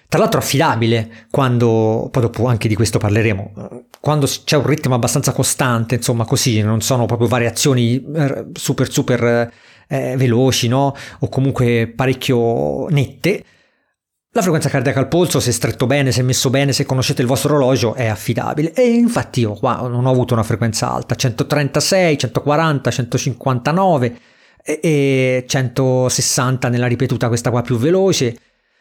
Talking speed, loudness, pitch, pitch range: 145 wpm, -16 LUFS, 130 Hz, 120-140 Hz